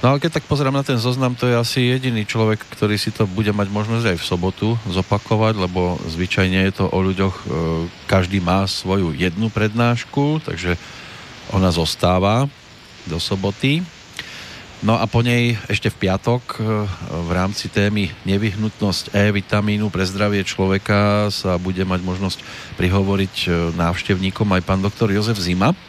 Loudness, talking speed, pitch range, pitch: -19 LUFS, 150 wpm, 95-115 Hz, 100 Hz